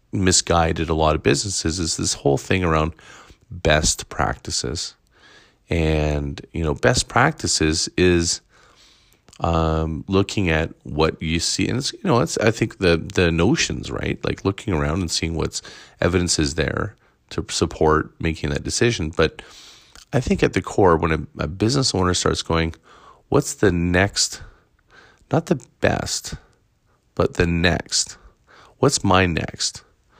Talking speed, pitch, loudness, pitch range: 145 wpm, 85 Hz, -21 LUFS, 80-95 Hz